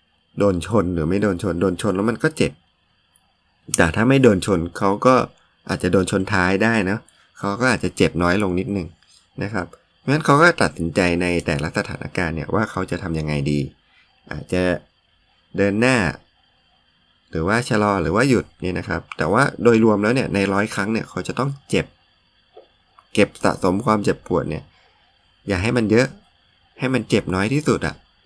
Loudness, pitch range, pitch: -20 LUFS, 85-110 Hz, 95 Hz